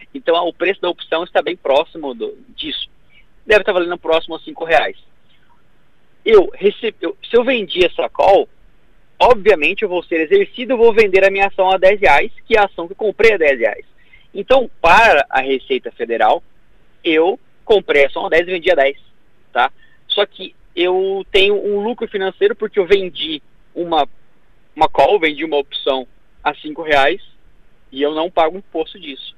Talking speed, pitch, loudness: 185 wpm, 195 Hz, -15 LUFS